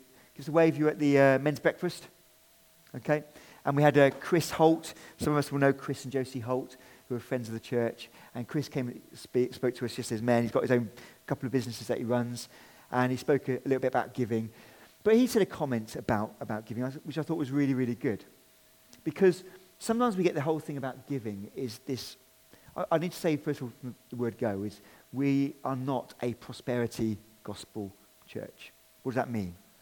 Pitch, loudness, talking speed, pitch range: 130 Hz, -30 LUFS, 225 wpm, 120-150 Hz